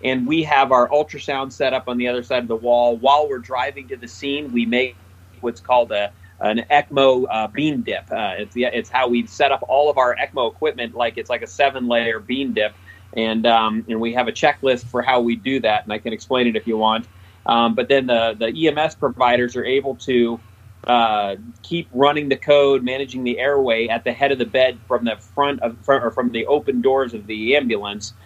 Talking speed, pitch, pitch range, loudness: 230 wpm, 120 Hz, 115-135 Hz, -19 LUFS